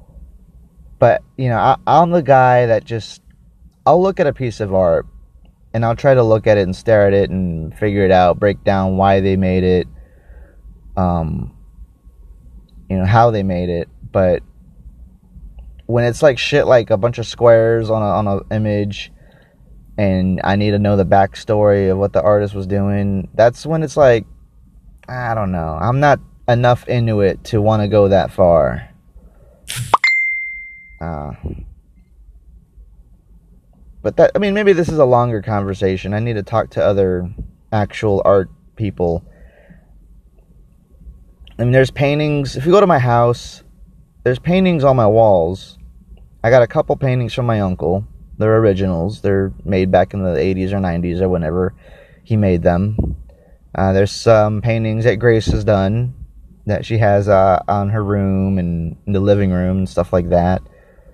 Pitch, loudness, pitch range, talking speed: 100 Hz, -15 LUFS, 85-115 Hz, 170 wpm